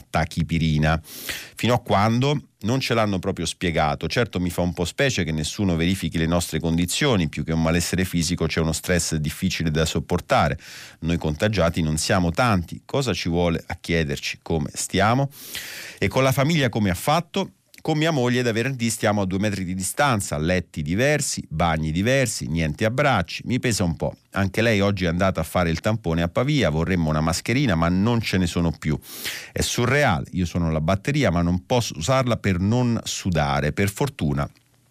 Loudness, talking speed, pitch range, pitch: -22 LUFS, 180 wpm, 80-115 Hz, 90 Hz